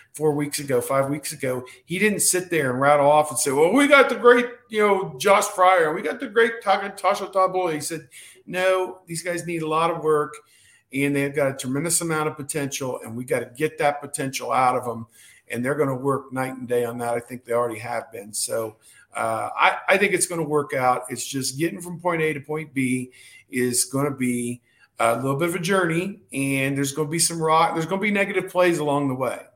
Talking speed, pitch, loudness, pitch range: 245 wpm, 150 Hz, -22 LUFS, 130-180 Hz